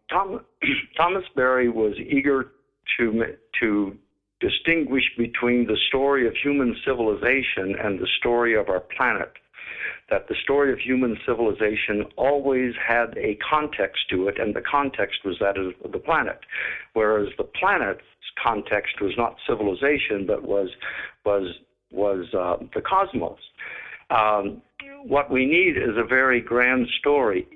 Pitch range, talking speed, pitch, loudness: 105-140 Hz, 135 wpm, 120 Hz, -23 LUFS